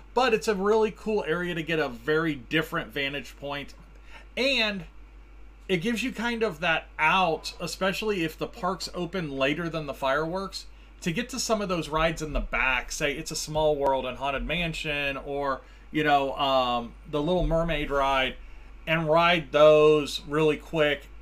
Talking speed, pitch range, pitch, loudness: 170 wpm, 140-180 Hz, 155 Hz, -26 LUFS